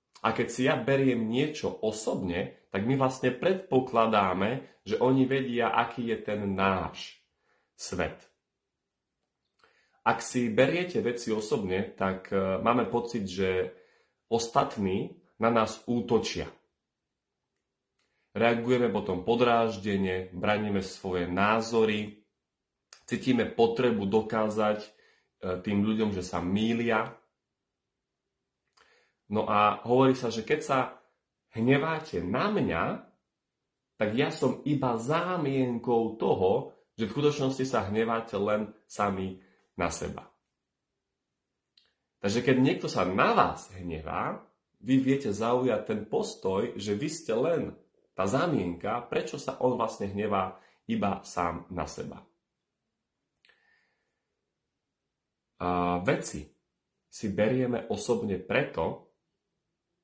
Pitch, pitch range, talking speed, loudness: 110 Hz, 100-125 Hz, 105 wpm, -29 LUFS